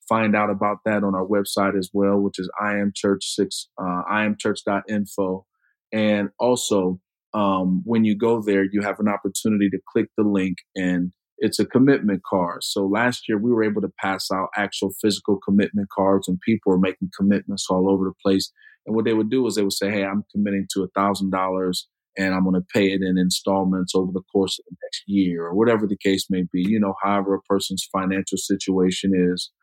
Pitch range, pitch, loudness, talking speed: 95-105 Hz, 100 Hz, -22 LUFS, 200 wpm